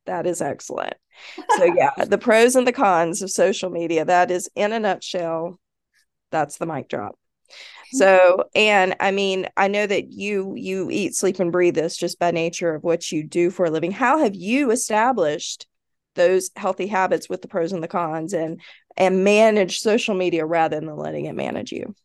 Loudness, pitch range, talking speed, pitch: -20 LUFS, 170-205 Hz, 190 wpm, 185 Hz